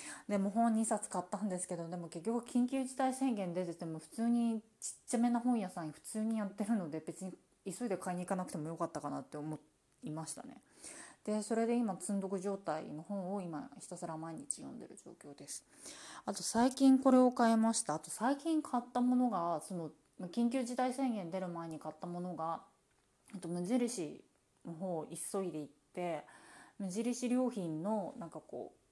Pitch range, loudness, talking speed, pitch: 170-240 Hz, -37 LUFS, 350 characters per minute, 200 Hz